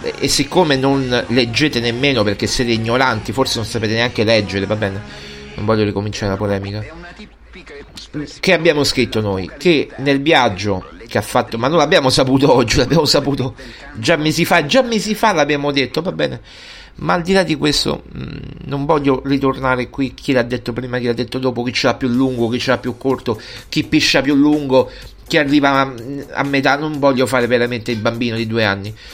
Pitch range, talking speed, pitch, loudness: 115-145 Hz, 190 wpm, 130 Hz, -16 LUFS